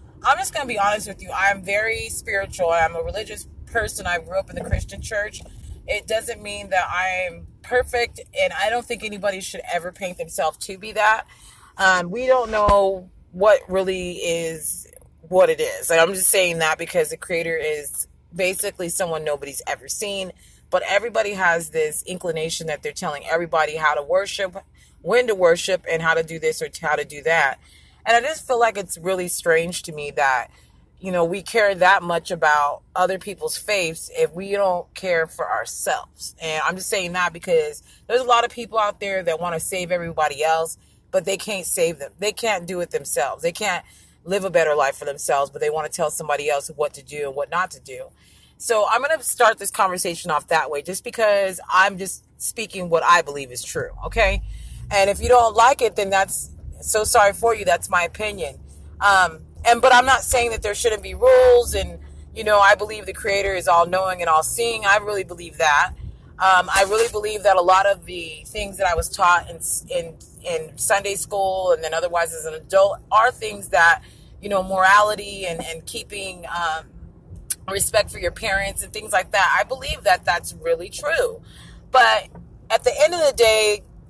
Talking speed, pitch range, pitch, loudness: 205 wpm, 170-220 Hz, 190 Hz, -20 LUFS